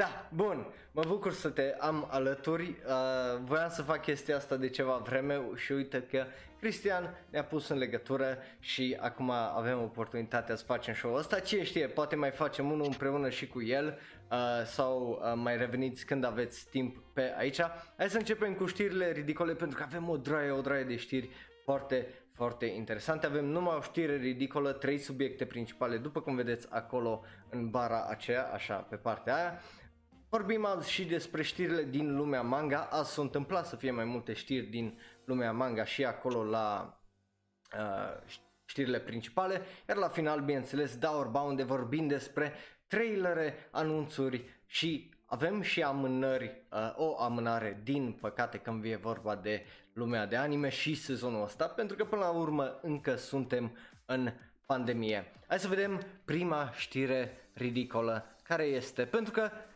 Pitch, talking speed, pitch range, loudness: 135 Hz, 165 wpm, 120-155 Hz, -35 LUFS